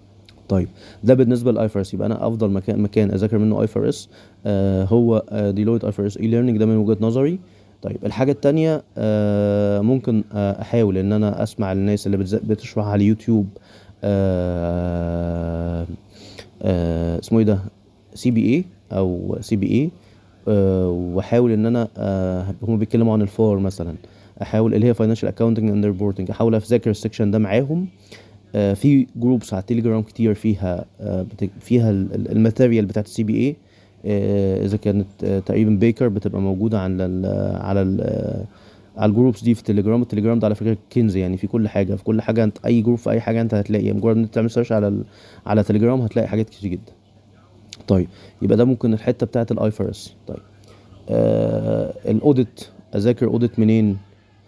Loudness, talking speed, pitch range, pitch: -20 LUFS, 155 wpm, 100-115 Hz, 105 Hz